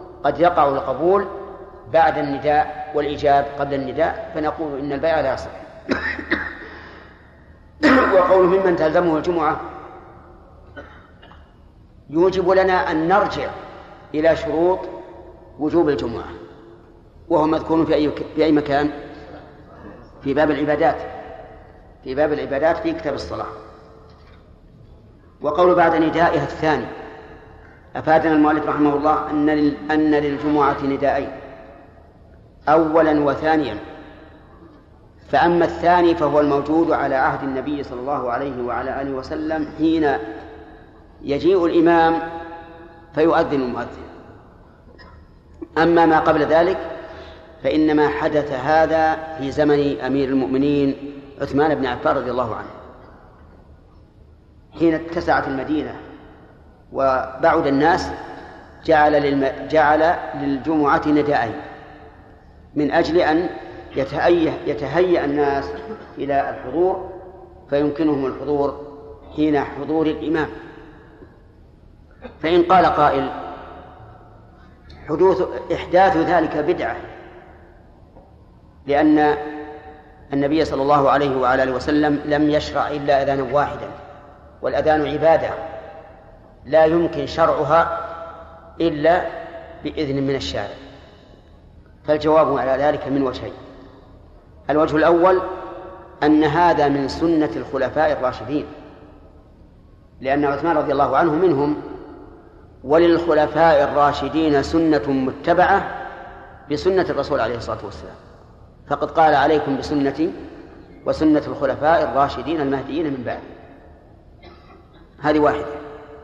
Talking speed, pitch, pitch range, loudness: 90 wpm, 150 Hz, 135-160 Hz, -19 LUFS